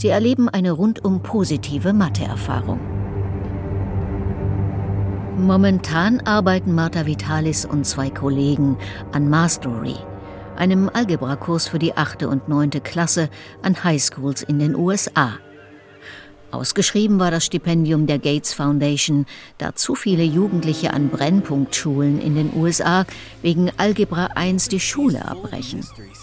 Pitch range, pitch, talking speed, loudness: 120-180 Hz, 150 Hz, 115 wpm, -19 LUFS